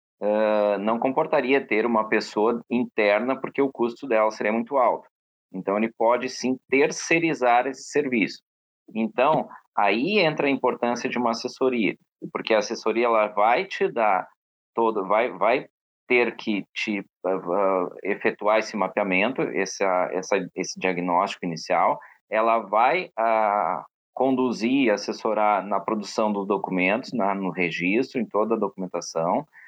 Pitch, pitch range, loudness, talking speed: 110 Hz, 100-120 Hz, -24 LUFS, 140 wpm